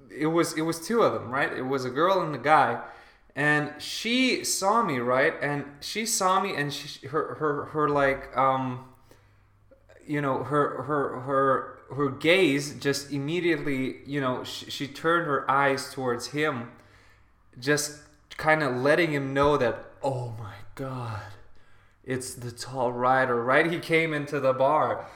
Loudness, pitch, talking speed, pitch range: -26 LUFS, 140 Hz, 165 wpm, 125-150 Hz